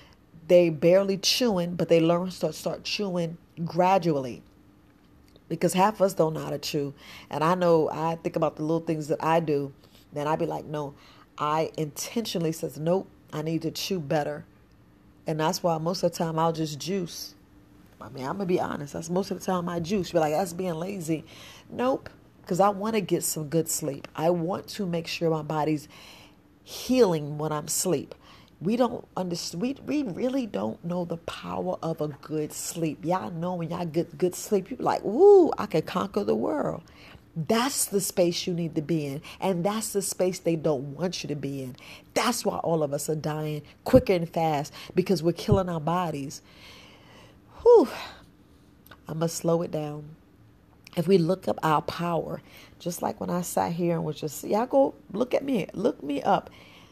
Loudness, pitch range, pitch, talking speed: -27 LUFS, 155-185 Hz, 170 Hz, 200 wpm